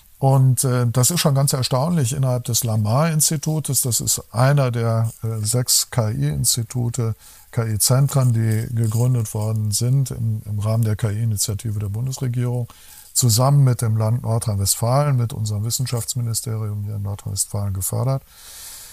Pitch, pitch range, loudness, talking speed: 120 Hz, 110-130 Hz, -20 LUFS, 130 wpm